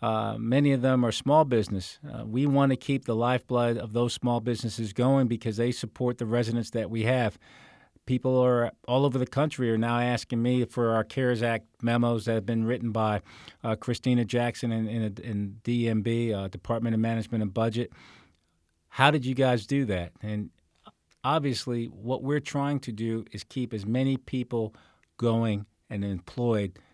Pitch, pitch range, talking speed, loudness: 115 Hz, 110-125 Hz, 180 wpm, -28 LUFS